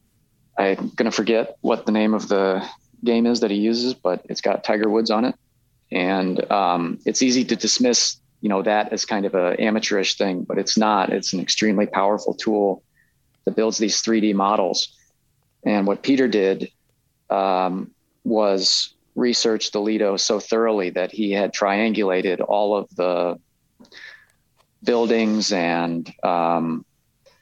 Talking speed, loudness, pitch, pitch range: 155 wpm, -21 LUFS, 105 Hz, 95-115 Hz